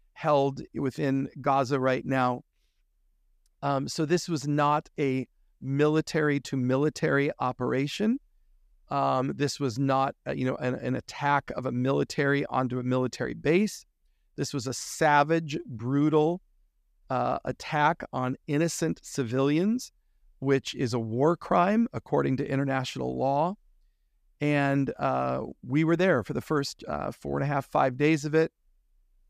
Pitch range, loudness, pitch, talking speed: 125-150 Hz, -28 LUFS, 140 Hz, 140 wpm